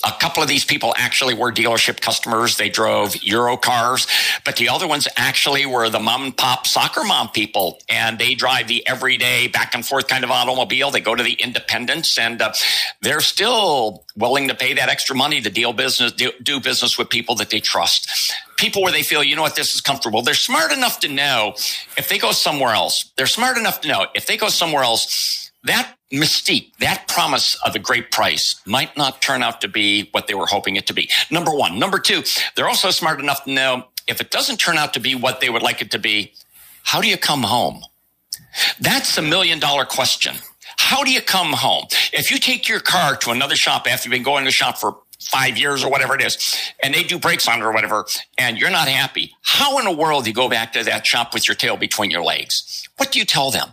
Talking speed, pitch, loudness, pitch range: 230 wpm, 130 Hz, -17 LUFS, 115-150 Hz